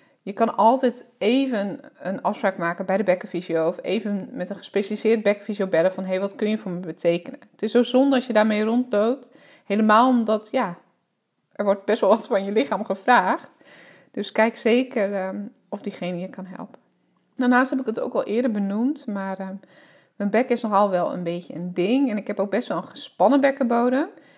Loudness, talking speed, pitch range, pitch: -22 LUFS, 200 wpm, 190-240 Hz, 210 Hz